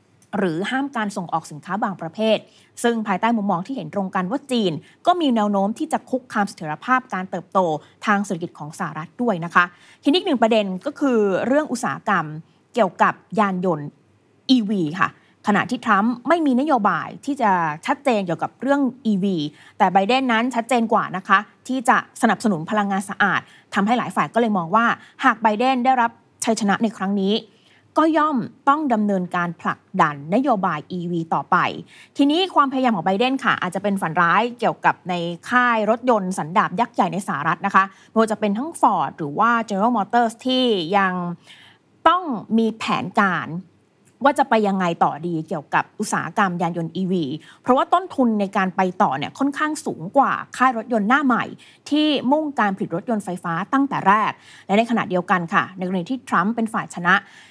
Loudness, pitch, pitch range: -21 LUFS, 210 Hz, 185-250 Hz